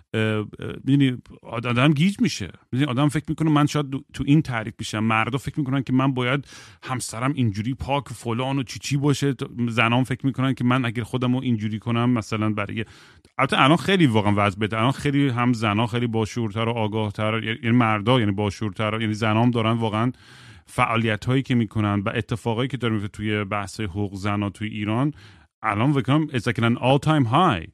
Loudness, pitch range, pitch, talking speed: -23 LUFS, 110-135 Hz, 120 Hz, 165 wpm